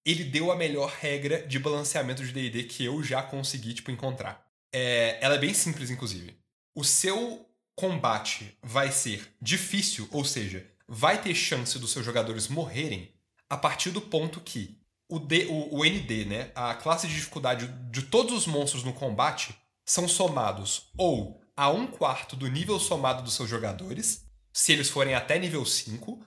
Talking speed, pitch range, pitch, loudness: 170 wpm, 115-160 Hz, 135 Hz, -28 LUFS